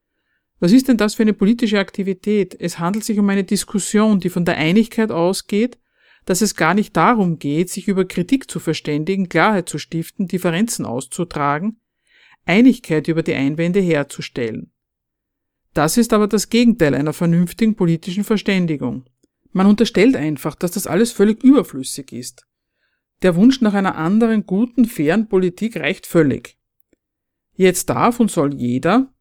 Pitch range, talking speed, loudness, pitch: 165-220 Hz, 150 wpm, -17 LUFS, 195 Hz